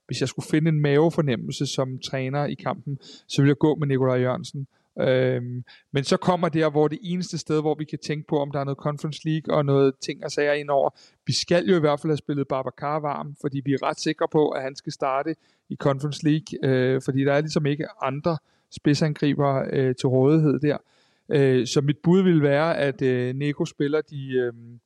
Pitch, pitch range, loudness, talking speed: 145 Hz, 135-155 Hz, -24 LUFS, 220 wpm